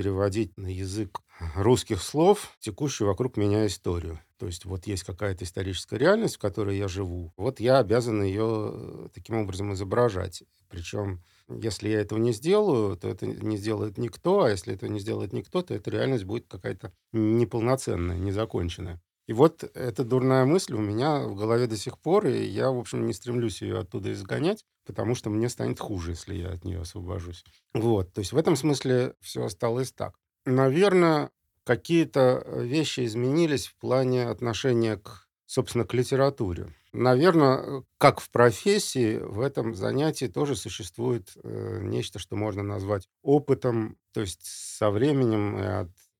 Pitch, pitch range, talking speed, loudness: 110 Hz, 100-125 Hz, 160 wpm, -27 LUFS